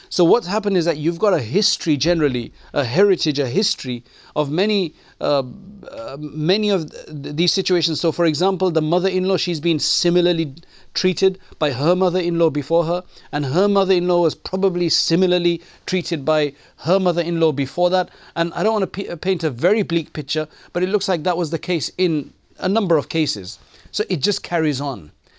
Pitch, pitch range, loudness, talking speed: 170 Hz, 155-185 Hz, -19 LUFS, 185 wpm